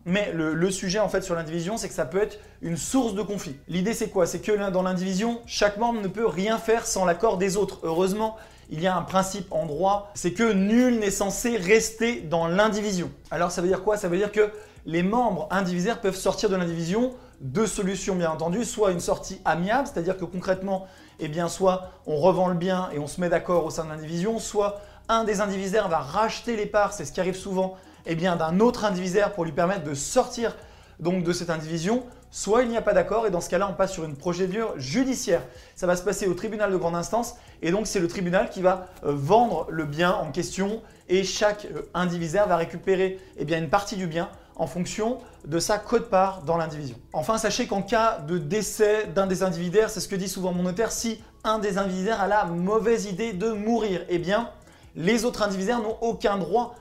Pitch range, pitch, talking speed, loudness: 175-215 Hz, 195 Hz, 225 wpm, -25 LUFS